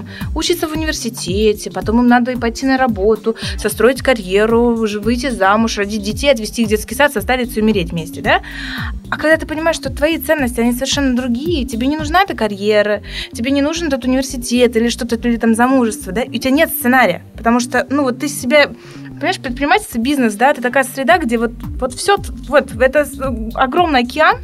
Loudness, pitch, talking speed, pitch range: -15 LUFS, 250 Hz, 190 wpm, 225-280 Hz